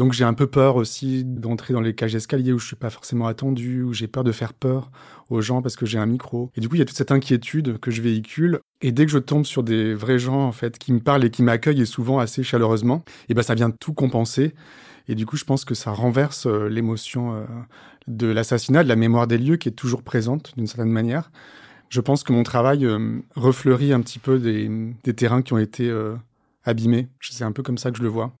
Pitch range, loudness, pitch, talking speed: 115-135 Hz, -22 LUFS, 120 Hz, 260 wpm